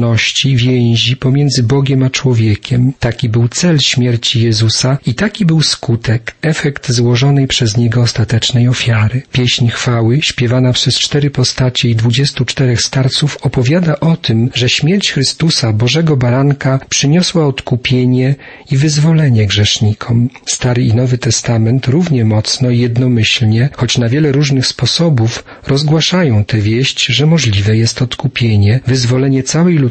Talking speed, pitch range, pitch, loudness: 130 wpm, 120-140 Hz, 125 Hz, -11 LUFS